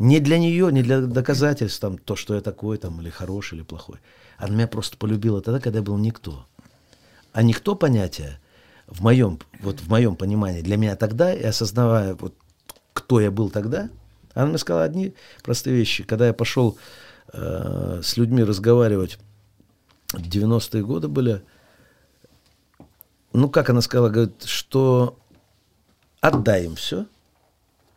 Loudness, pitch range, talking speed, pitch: -21 LUFS, 100-120 Hz, 150 wpm, 110 Hz